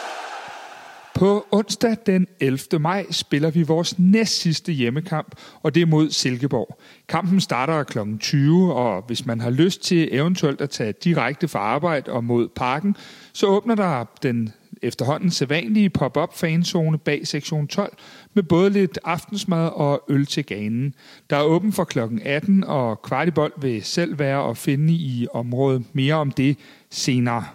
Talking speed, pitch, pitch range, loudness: 155 wpm, 155 Hz, 135-185 Hz, -21 LUFS